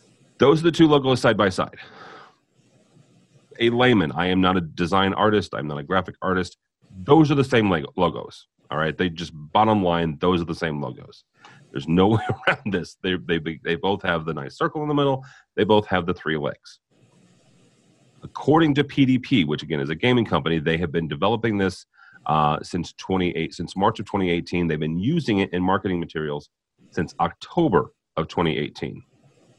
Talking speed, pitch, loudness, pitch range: 190 wpm, 95 Hz, -22 LUFS, 85-120 Hz